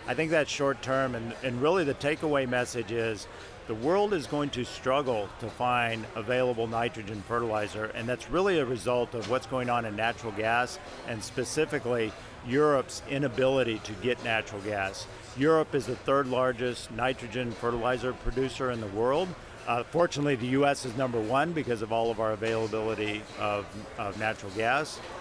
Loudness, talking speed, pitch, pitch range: -29 LUFS, 170 wpm, 120 Hz, 110-130 Hz